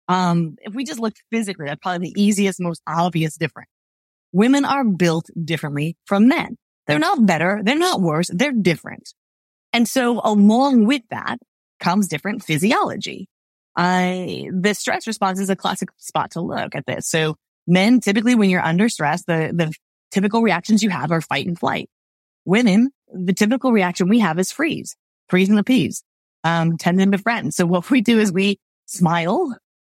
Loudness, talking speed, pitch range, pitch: -19 LUFS, 175 wpm, 170-220 Hz, 190 Hz